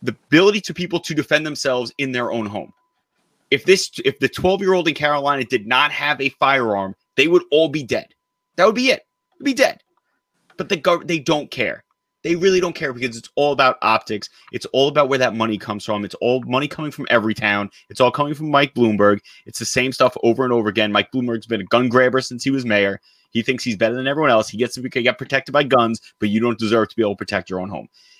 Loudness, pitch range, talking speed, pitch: -19 LUFS, 115-150 Hz, 250 wpm, 130 Hz